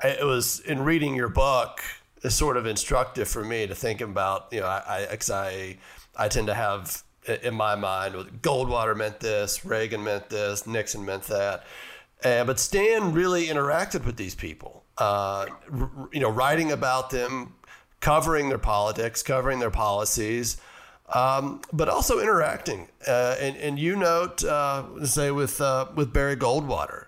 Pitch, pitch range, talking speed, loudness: 130 Hz, 105-145 Hz, 165 wpm, -26 LUFS